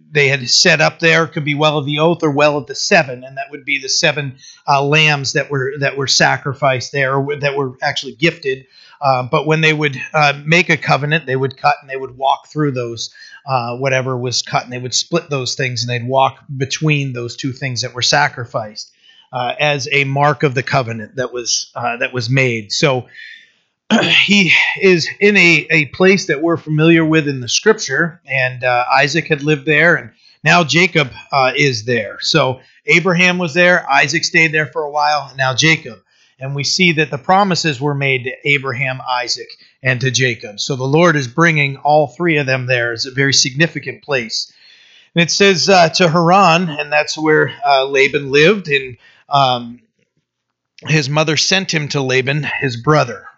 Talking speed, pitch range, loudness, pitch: 200 wpm, 130-160 Hz, -14 LUFS, 145 Hz